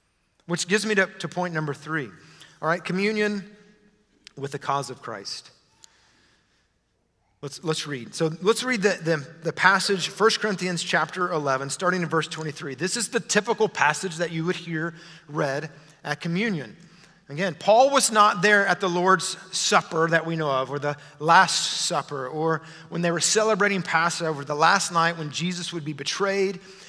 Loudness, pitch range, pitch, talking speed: -23 LUFS, 155-195 Hz, 170 Hz, 170 wpm